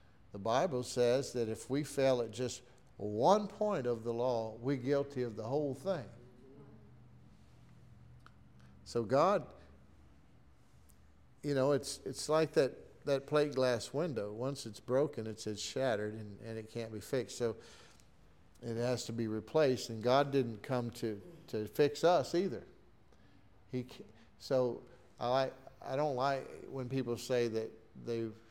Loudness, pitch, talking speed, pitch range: -35 LUFS, 120 Hz, 145 wpm, 110-135 Hz